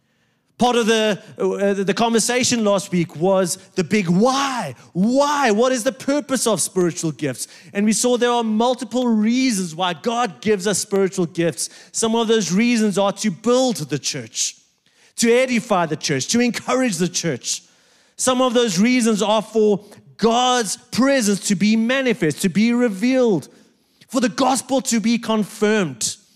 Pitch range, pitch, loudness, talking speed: 190-245 Hz, 220 Hz, -19 LUFS, 160 wpm